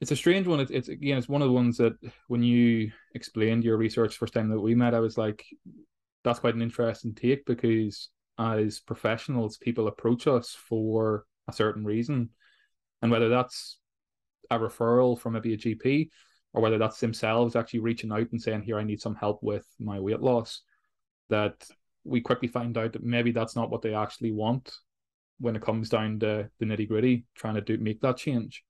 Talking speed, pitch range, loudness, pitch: 205 wpm, 110-120 Hz, -28 LUFS, 115 Hz